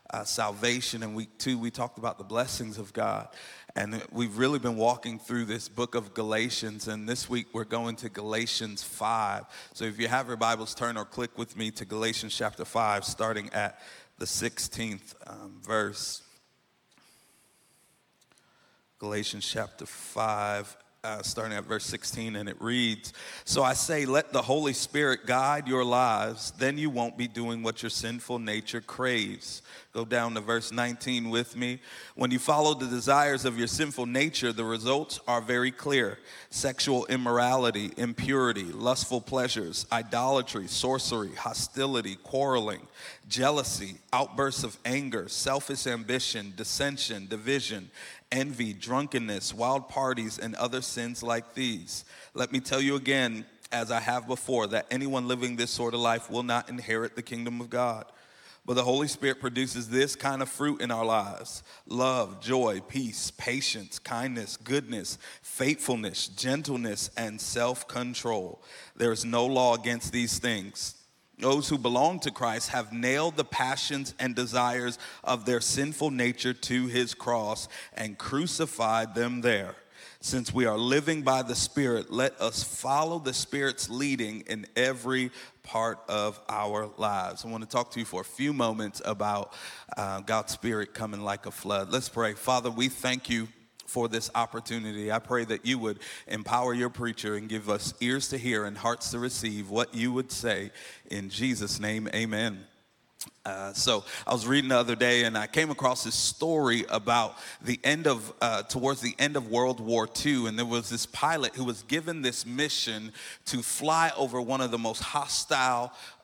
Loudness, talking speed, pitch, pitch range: -29 LUFS, 165 wpm, 120 Hz, 110-130 Hz